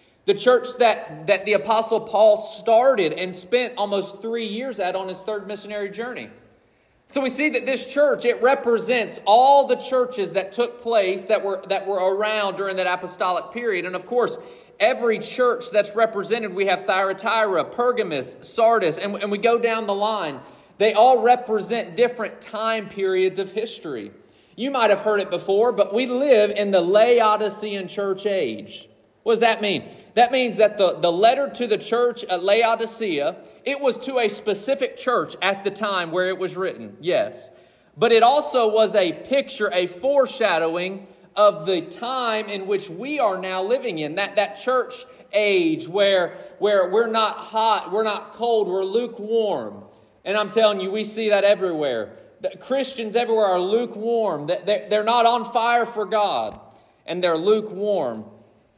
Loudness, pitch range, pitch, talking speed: -21 LUFS, 195-235 Hz, 215 Hz, 170 wpm